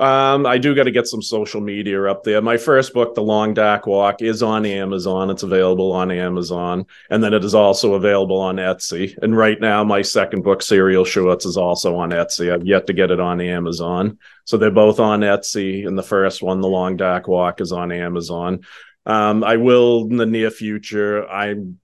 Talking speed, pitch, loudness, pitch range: 210 wpm, 100 Hz, -17 LUFS, 90-110 Hz